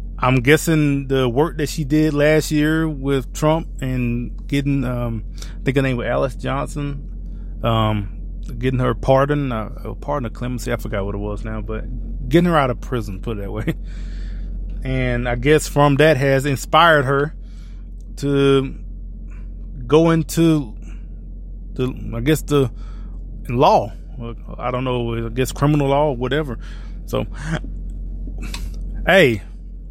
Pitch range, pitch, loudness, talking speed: 105-140 Hz, 120 Hz, -19 LUFS, 145 wpm